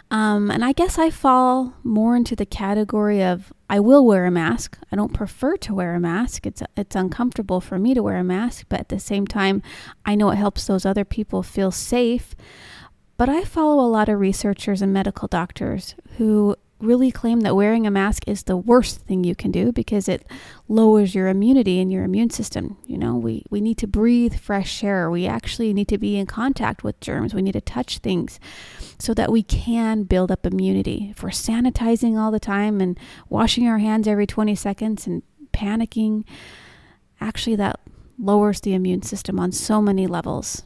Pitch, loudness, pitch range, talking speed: 210 Hz, -20 LUFS, 195-230 Hz, 200 wpm